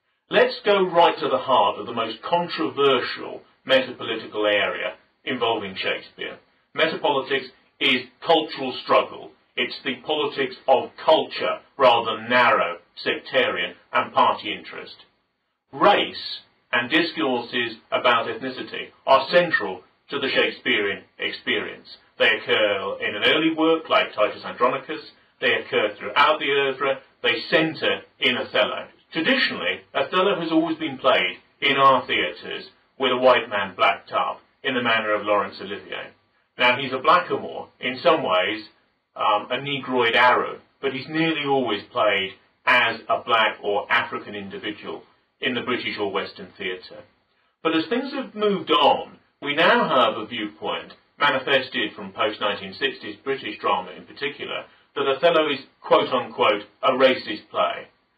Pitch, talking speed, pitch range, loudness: 140 Hz, 135 wpm, 125-175 Hz, -22 LUFS